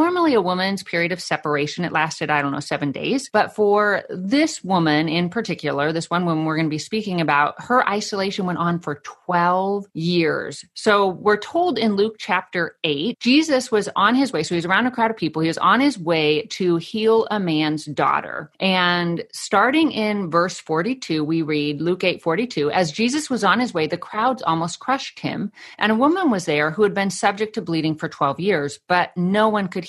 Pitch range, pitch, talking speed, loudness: 160-215 Hz, 185 Hz, 205 wpm, -20 LUFS